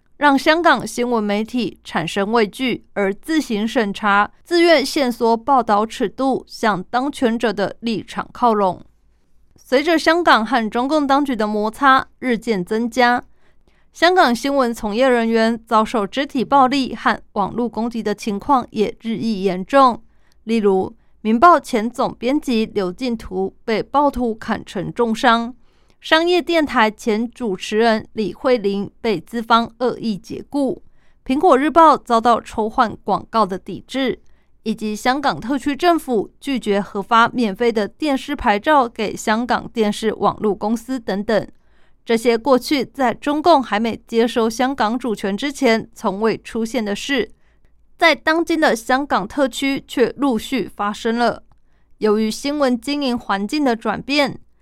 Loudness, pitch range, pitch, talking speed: -18 LUFS, 215-265 Hz, 235 Hz, 225 characters per minute